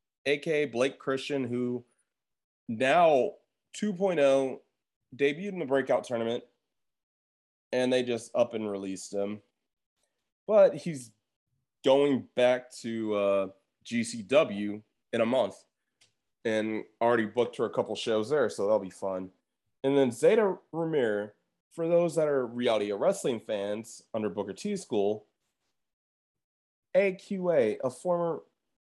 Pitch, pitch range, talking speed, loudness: 125 Hz, 105-150 Hz, 120 wpm, -29 LUFS